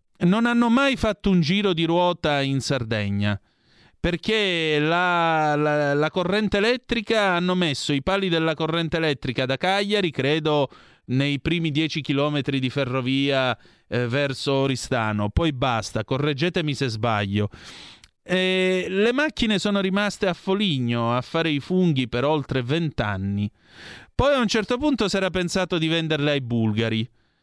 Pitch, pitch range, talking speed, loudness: 155 Hz, 130-185 Hz, 145 wpm, -23 LUFS